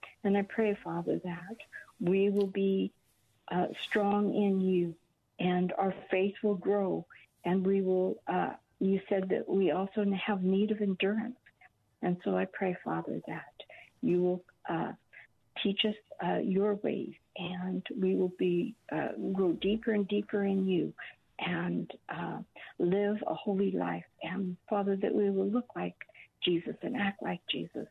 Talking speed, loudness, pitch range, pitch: 155 wpm, -32 LUFS, 180-205 Hz, 195 Hz